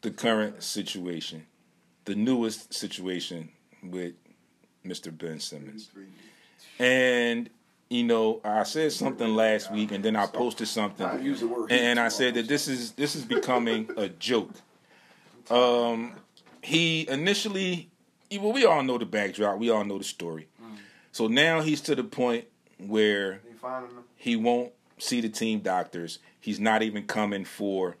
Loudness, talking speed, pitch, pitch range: -27 LUFS, 140 wpm, 115 Hz, 105-125 Hz